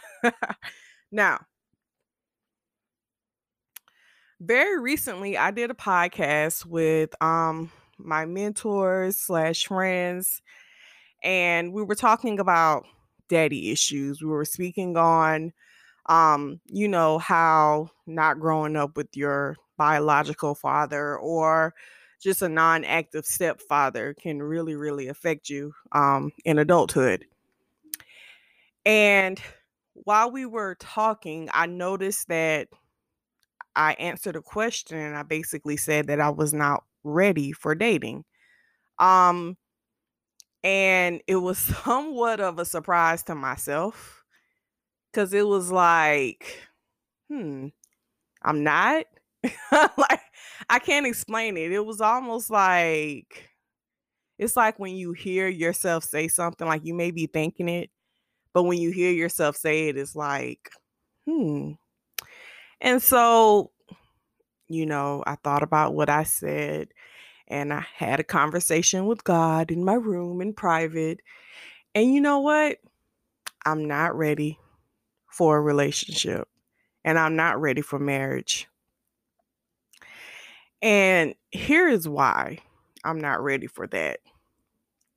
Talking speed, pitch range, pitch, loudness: 120 wpm, 155-195 Hz, 165 Hz, -24 LUFS